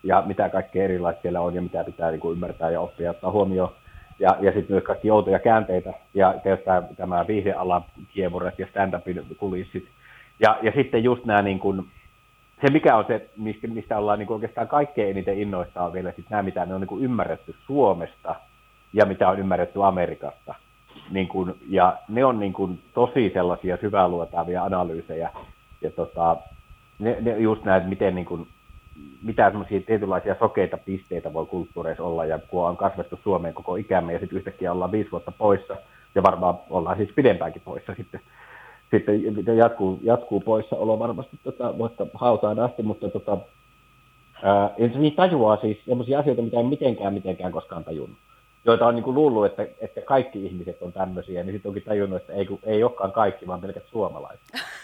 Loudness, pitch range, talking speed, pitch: -24 LUFS, 90-115 Hz, 175 wpm, 100 Hz